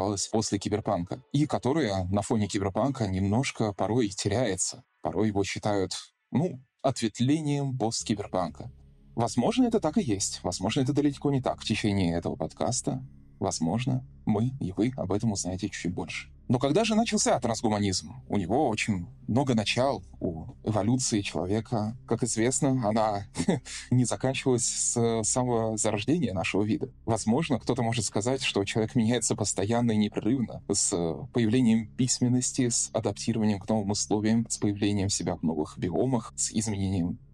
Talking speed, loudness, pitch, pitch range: 145 wpm, -28 LUFS, 110 Hz, 100-125 Hz